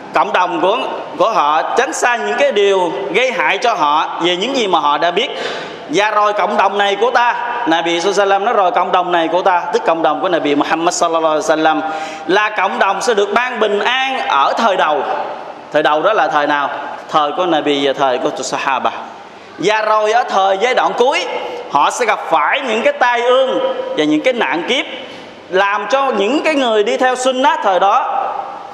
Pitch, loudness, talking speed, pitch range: 205 Hz, -14 LUFS, 215 wpm, 175-255 Hz